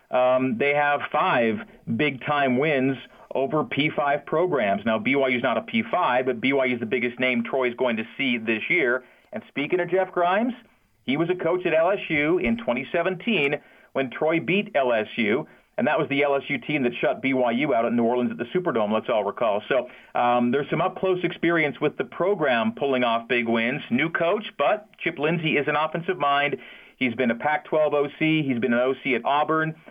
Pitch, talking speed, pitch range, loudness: 140 Hz, 195 wpm, 125-160 Hz, -23 LUFS